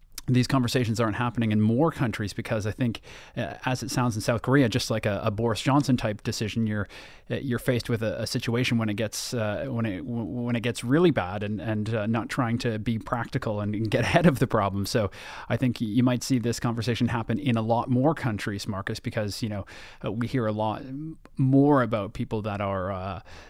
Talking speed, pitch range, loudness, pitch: 220 wpm, 110-125 Hz, -26 LUFS, 115 Hz